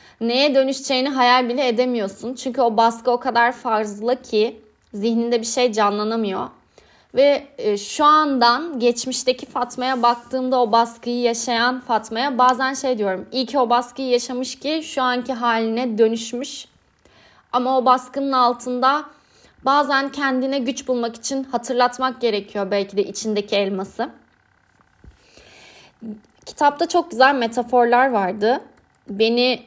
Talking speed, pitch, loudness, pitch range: 120 wpm, 245 Hz, -20 LUFS, 230-265 Hz